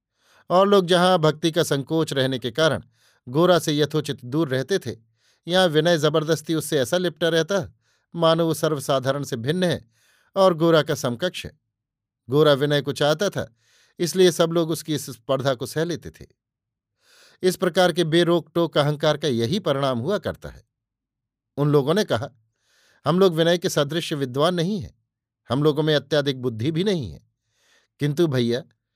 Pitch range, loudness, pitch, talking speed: 130-170 Hz, -22 LUFS, 150 Hz, 170 wpm